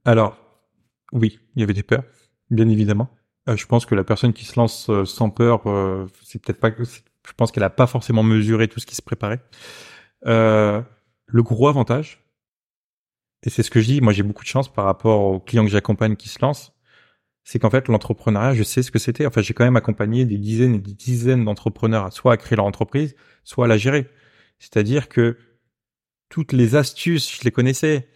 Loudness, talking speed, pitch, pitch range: -19 LUFS, 215 wpm, 115 Hz, 110-125 Hz